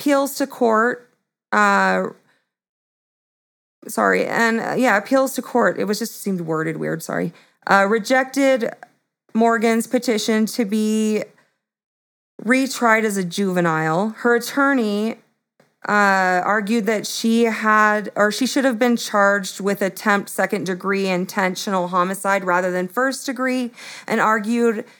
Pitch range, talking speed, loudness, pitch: 195-240 Hz, 125 wpm, -19 LUFS, 220 Hz